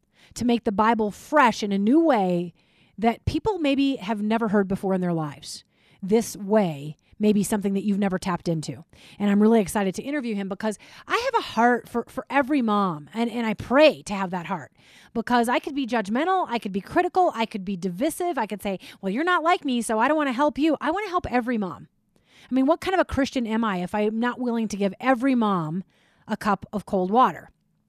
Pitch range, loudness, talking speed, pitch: 200-275 Hz, -24 LUFS, 230 wpm, 225 Hz